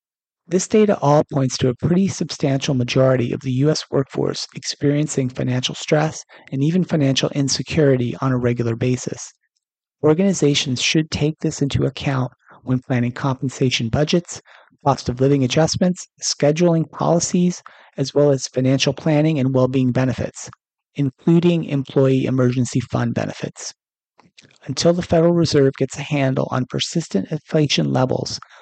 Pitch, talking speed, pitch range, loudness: 140 Hz, 135 wpm, 130-160 Hz, -19 LUFS